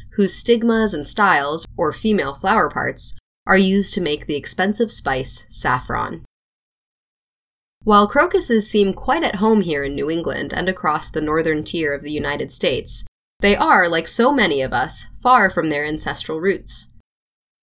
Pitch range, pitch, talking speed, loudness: 155-215 Hz, 190 Hz, 160 wpm, -17 LUFS